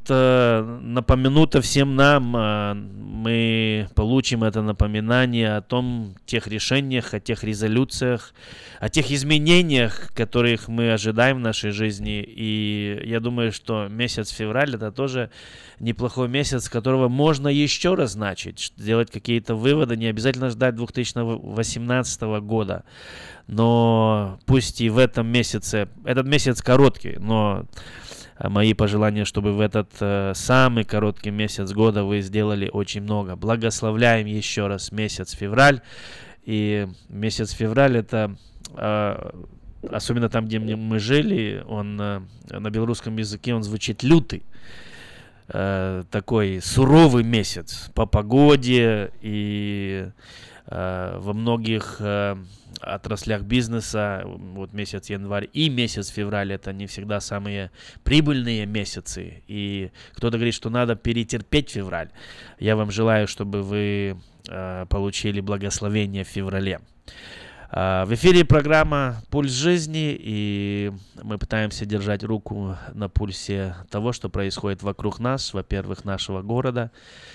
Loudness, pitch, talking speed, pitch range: -22 LUFS, 110 Hz, 120 wpm, 100-120 Hz